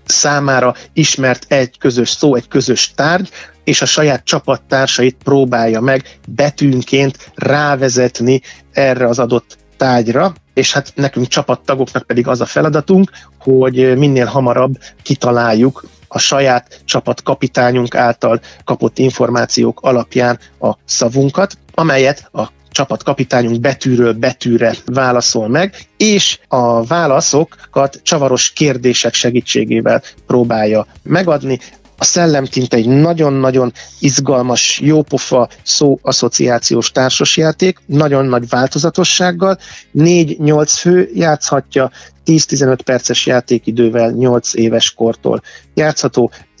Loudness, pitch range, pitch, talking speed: -12 LUFS, 120-145 Hz, 130 Hz, 100 wpm